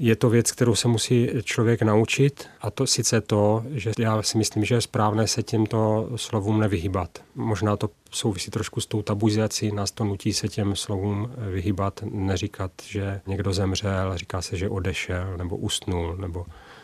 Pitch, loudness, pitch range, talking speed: 105 Hz, -25 LUFS, 100-115 Hz, 170 wpm